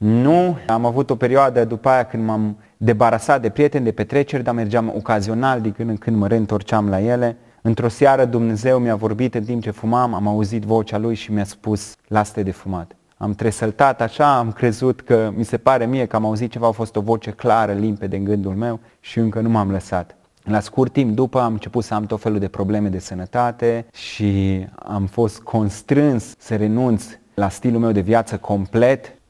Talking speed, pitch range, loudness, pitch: 205 wpm, 105-120 Hz, -19 LUFS, 115 Hz